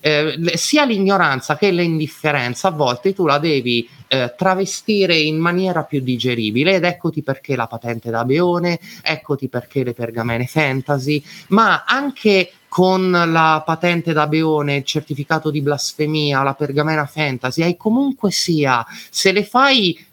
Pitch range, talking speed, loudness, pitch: 140-180 Hz, 145 wpm, -17 LUFS, 155 Hz